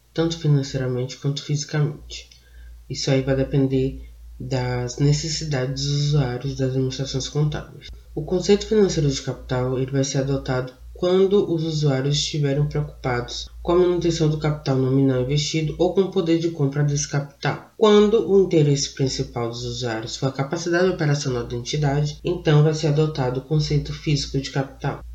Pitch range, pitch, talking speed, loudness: 130-155 Hz, 145 Hz, 155 wpm, -22 LUFS